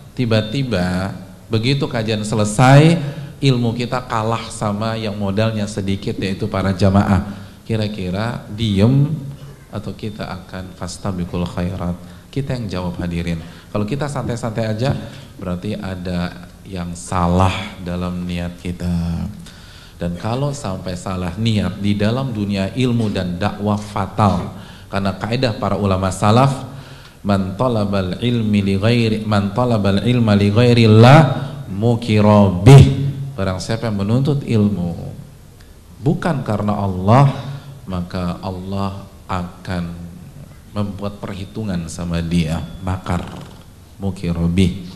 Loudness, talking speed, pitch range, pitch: -18 LUFS, 110 wpm, 90-115 Hz, 100 Hz